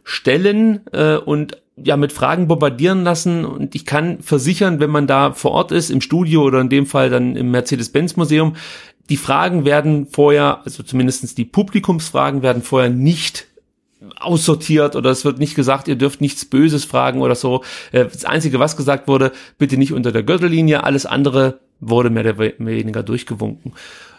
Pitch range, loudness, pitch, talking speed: 130-160 Hz, -16 LUFS, 145 Hz, 170 wpm